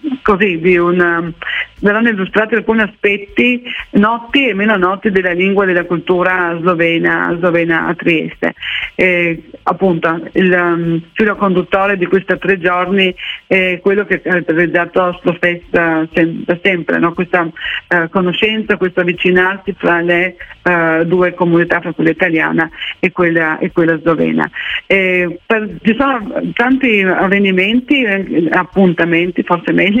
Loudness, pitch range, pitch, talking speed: -13 LUFS, 175-200 Hz, 180 Hz, 130 wpm